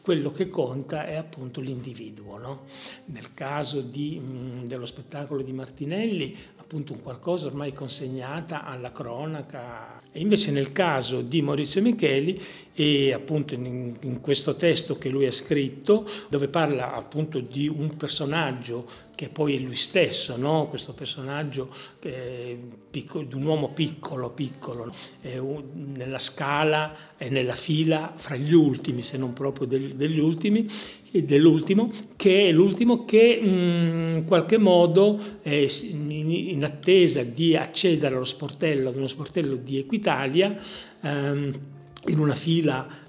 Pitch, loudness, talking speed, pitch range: 145 Hz, -24 LUFS, 130 wpm, 135-165 Hz